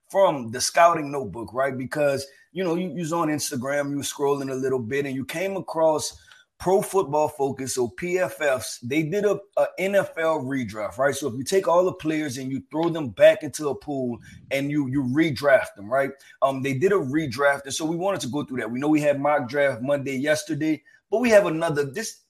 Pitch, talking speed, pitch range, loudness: 145 Hz, 215 wpm, 135-170 Hz, -24 LUFS